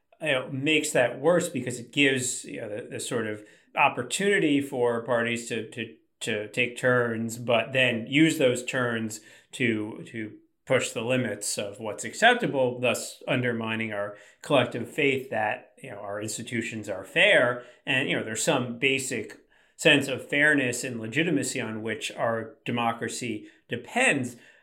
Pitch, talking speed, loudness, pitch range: 125 Hz, 155 wpm, -26 LUFS, 115-135 Hz